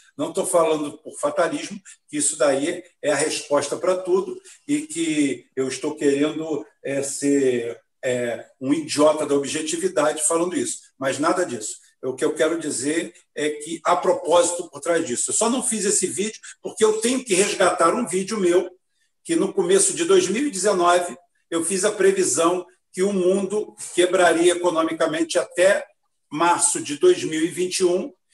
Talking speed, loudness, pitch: 155 wpm, -21 LUFS, 180 Hz